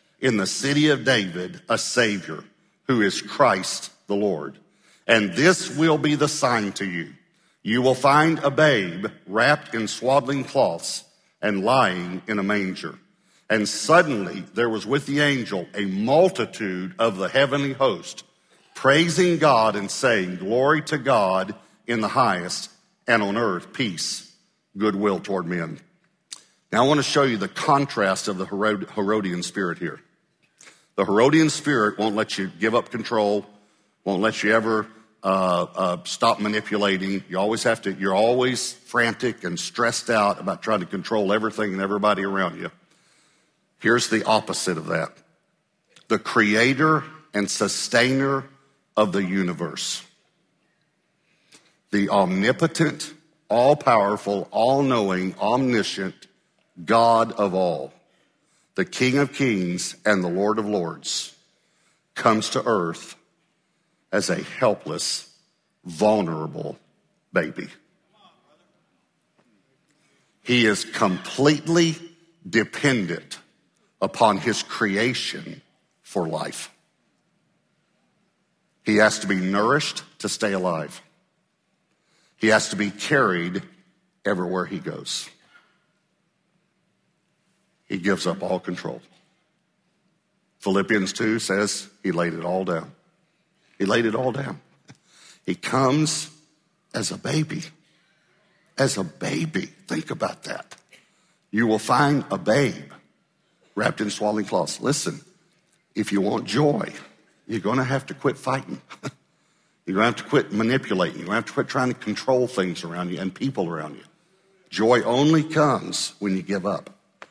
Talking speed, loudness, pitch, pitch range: 130 wpm, -22 LUFS, 115 Hz, 100-150 Hz